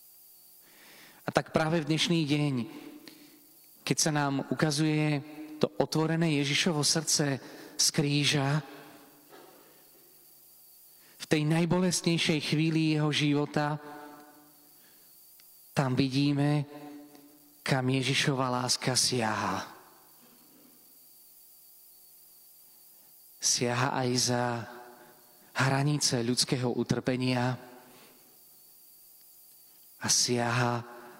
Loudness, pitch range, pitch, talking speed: -28 LUFS, 125-155 Hz, 145 Hz, 70 wpm